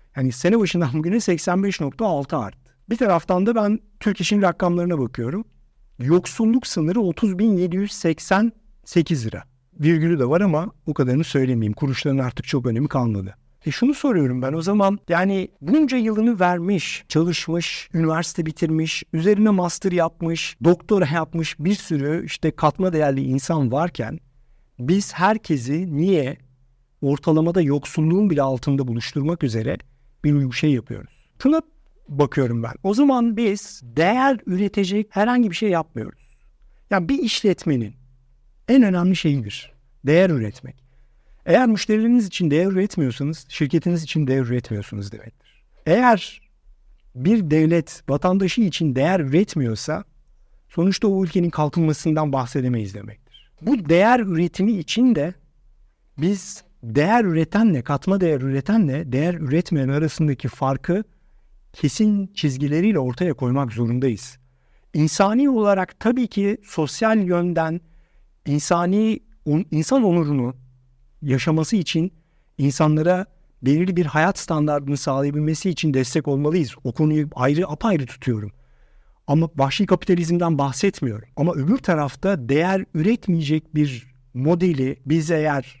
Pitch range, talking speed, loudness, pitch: 135-190 Hz, 115 wpm, -21 LUFS, 160 Hz